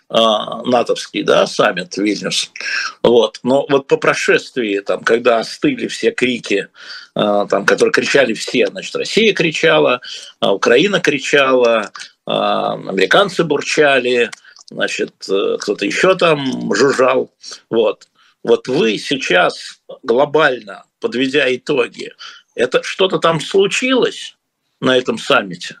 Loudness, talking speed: -15 LUFS, 100 wpm